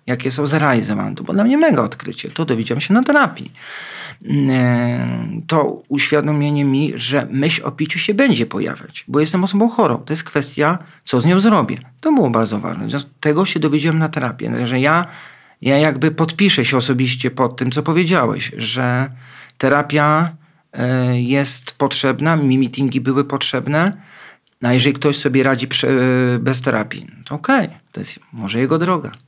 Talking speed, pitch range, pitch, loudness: 160 wpm, 130-160 Hz, 145 Hz, -17 LUFS